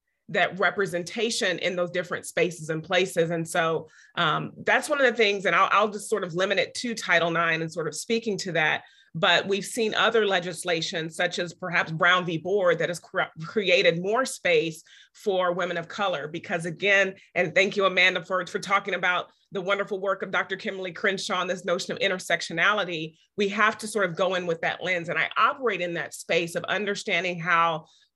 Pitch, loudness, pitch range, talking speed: 185 Hz, -25 LUFS, 170-200 Hz, 200 wpm